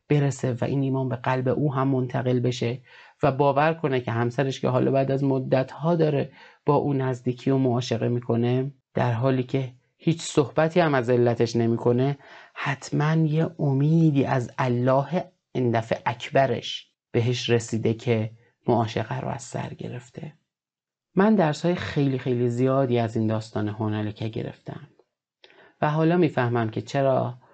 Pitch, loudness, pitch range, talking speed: 130 Hz, -24 LUFS, 120-145 Hz, 145 wpm